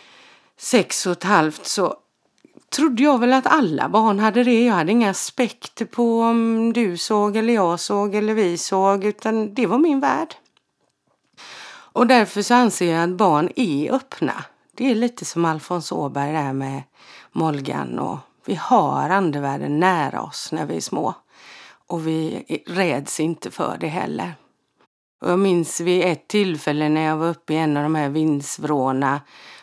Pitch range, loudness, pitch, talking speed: 155-230 Hz, -20 LUFS, 185 Hz, 165 wpm